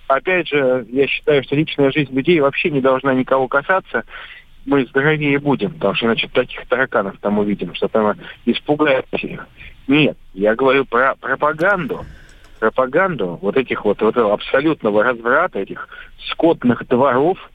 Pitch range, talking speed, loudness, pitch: 120-150 Hz, 145 wpm, -17 LUFS, 135 Hz